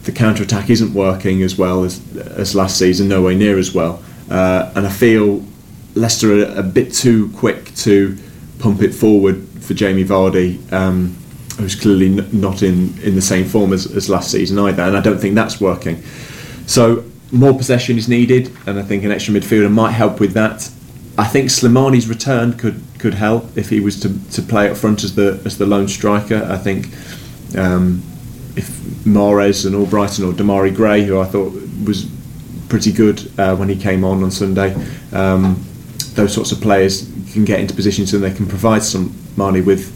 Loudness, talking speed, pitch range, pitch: -14 LUFS, 195 wpm, 95-110 Hz, 100 Hz